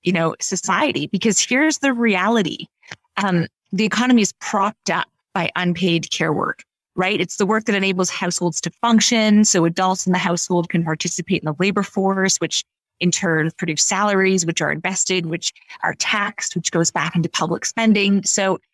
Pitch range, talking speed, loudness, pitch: 170-205 Hz, 175 wpm, -19 LUFS, 185 Hz